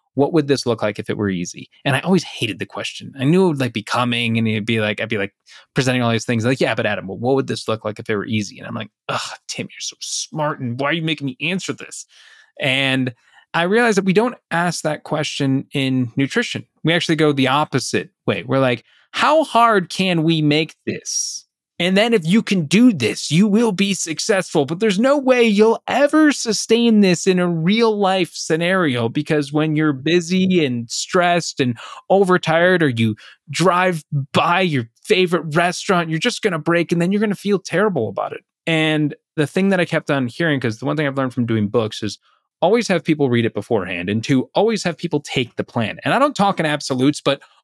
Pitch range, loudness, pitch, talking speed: 130-185 Hz, -18 LUFS, 155 Hz, 225 wpm